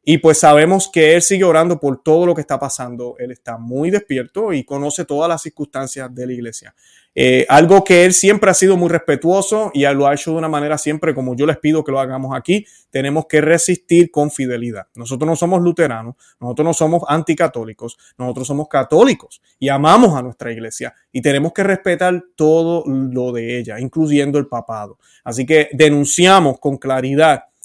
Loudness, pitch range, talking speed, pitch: -14 LUFS, 130-170 Hz, 190 wpm, 150 Hz